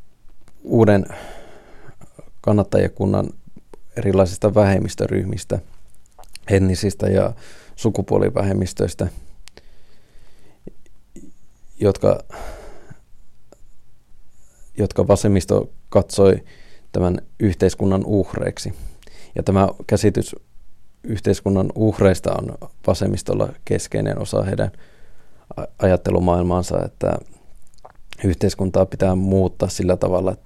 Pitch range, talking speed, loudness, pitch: 95-100 Hz, 65 wpm, -20 LUFS, 95 Hz